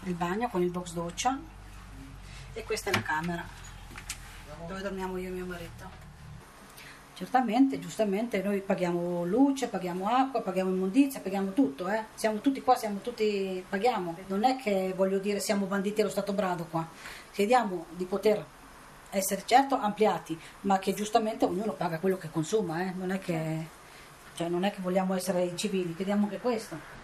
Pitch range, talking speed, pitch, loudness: 175-215 Hz, 165 wpm, 195 Hz, -30 LUFS